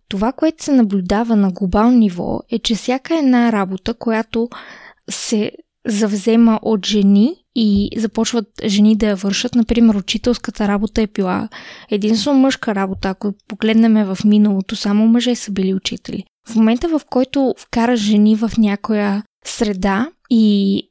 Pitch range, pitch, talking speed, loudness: 205-235 Hz, 220 Hz, 145 wpm, -16 LUFS